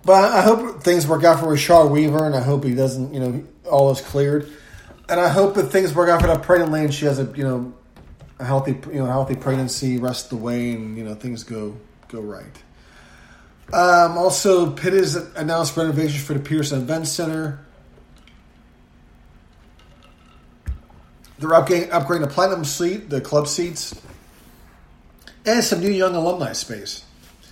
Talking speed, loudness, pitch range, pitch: 175 wpm, -19 LUFS, 120-170 Hz, 145 Hz